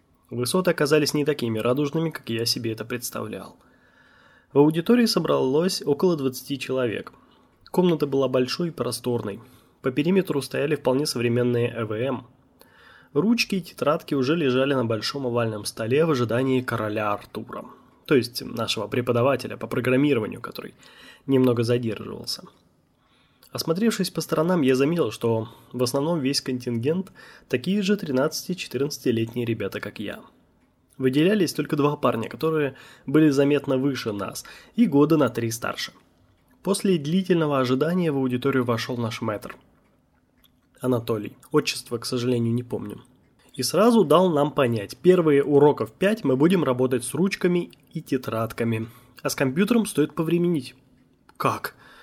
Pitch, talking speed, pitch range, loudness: 135 Hz, 130 wpm, 120-155 Hz, -23 LUFS